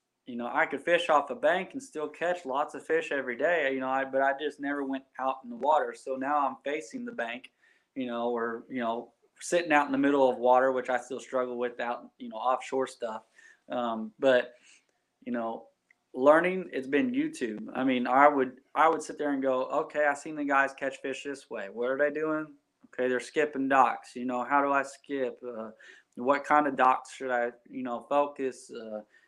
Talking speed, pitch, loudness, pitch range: 220 wpm, 135 Hz, -29 LUFS, 125-145 Hz